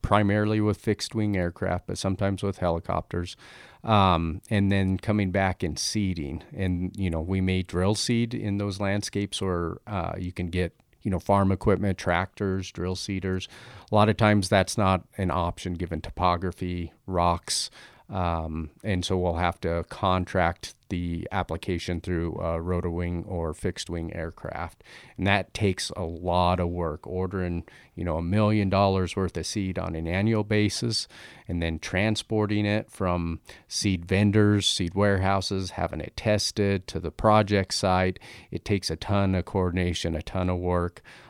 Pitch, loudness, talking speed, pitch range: 95 Hz, -27 LUFS, 165 wpm, 85-100 Hz